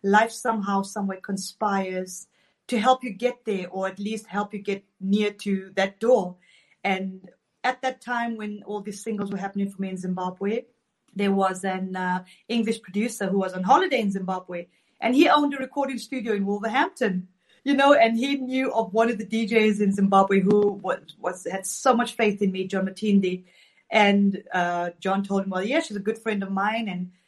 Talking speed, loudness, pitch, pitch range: 200 wpm, -24 LUFS, 205 Hz, 190-225 Hz